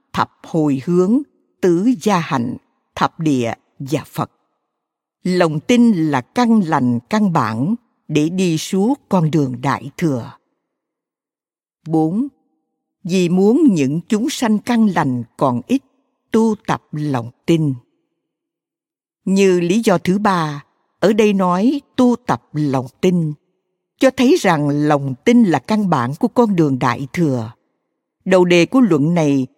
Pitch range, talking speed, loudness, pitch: 145-220 Hz, 140 wpm, -17 LUFS, 180 Hz